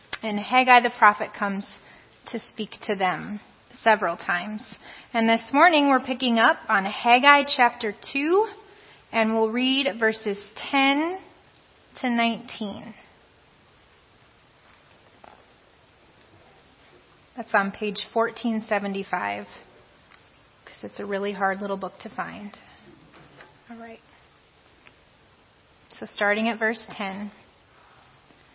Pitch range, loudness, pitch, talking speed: 205-245 Hz, -23 LUFS, 220 Hz, 100 wpm